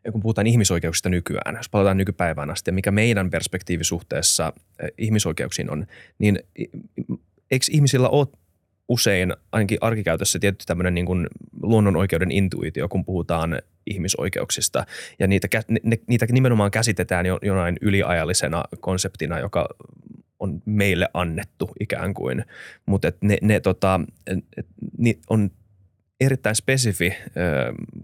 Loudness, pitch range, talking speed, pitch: -22 LUFS, 85-105 Hz, 120 wpm, 95 Hz